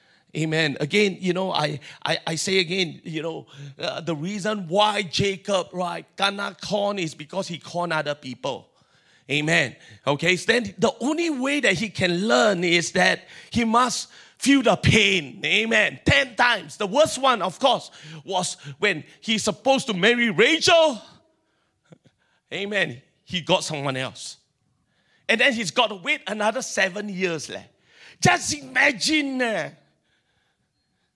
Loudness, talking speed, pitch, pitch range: -22 LUFS, 145 wpm, 195 Hz, 165-230 Hz